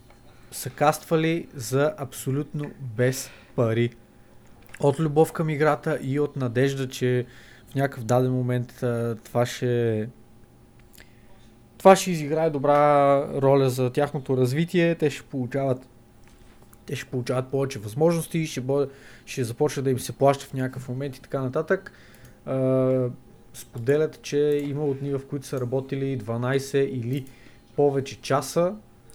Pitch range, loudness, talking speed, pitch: 120-145 Hz, -25 LUFS, 135 wpm, 130 Hz